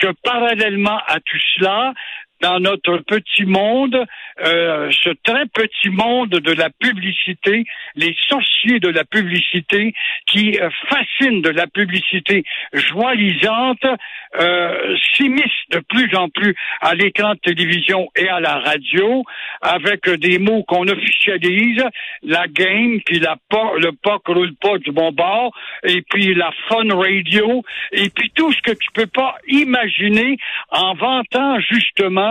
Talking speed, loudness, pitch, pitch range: 140 wpm, -15 LUFS, 200 Hz, 180-235 Hz